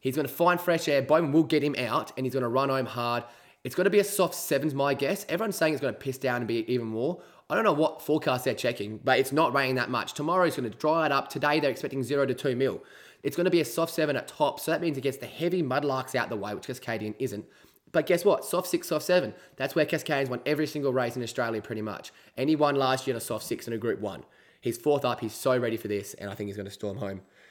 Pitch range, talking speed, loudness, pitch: 120-155 Hz, 295 wpm, -28 LUFS, 135 Hz